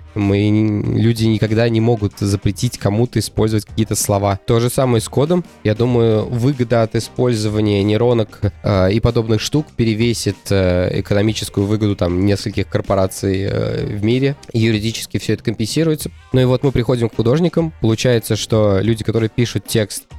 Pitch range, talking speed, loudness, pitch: 105-120 Hz, 155 wpm, -17 LUFS, 110 Hz